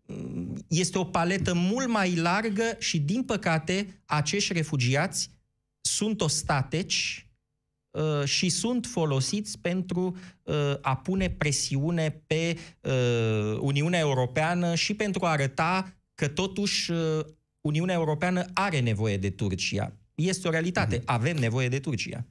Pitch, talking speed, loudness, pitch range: 160 Hz, 120 wpm, -27 LUFS, 140-185 Hz